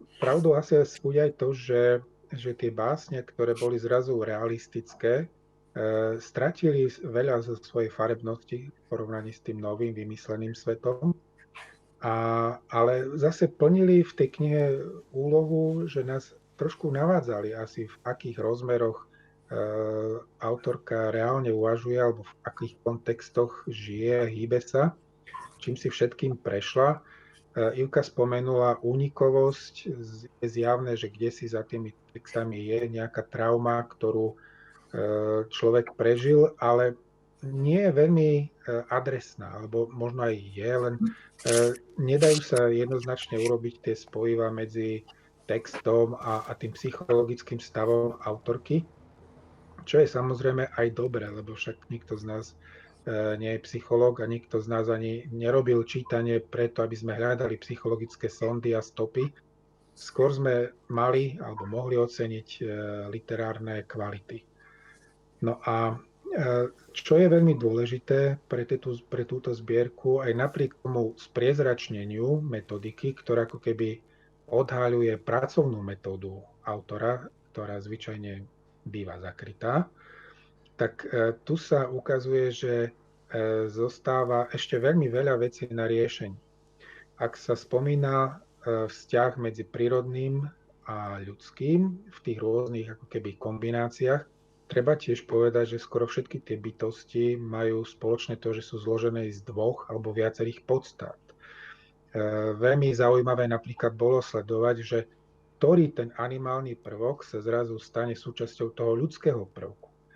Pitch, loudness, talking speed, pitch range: 120 Hz, -28 LUFS, 120 wpm, 115-130 Hz